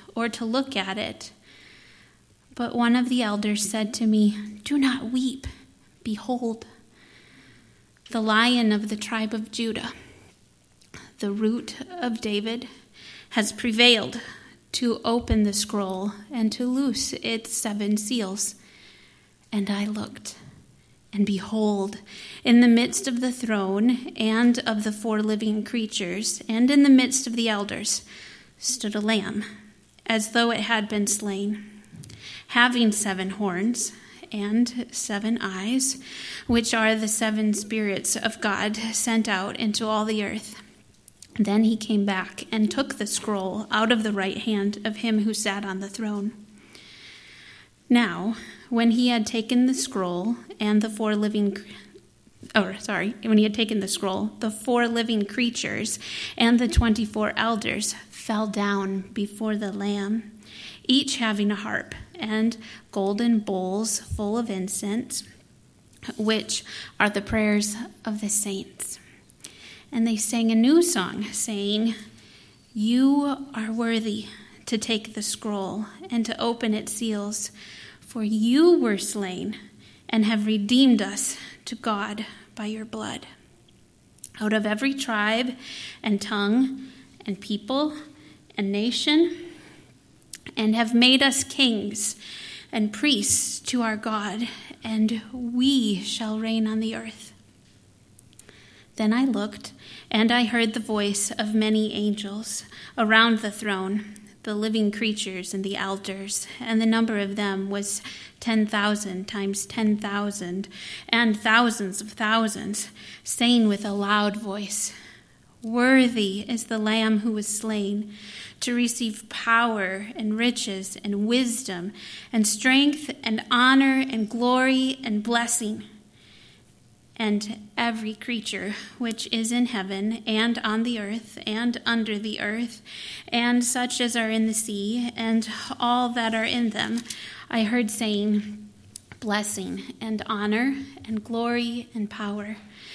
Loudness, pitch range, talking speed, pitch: -24 LUFS, 210-235 Hz, 135 wpm, 220 Hz